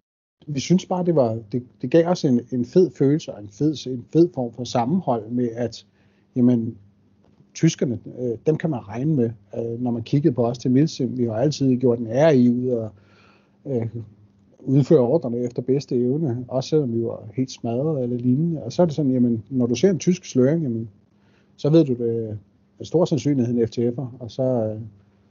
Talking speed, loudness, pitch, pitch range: 205 wpm, -22 LUFS, 125 Hz, 115-145 Hz